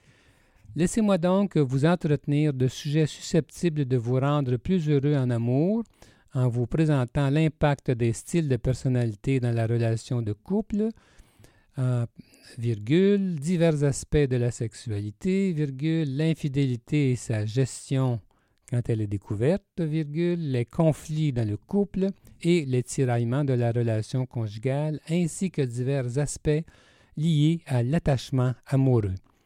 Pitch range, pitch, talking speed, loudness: 120-160 Hz, 140 Hz, 130 wpm, -26 LUFS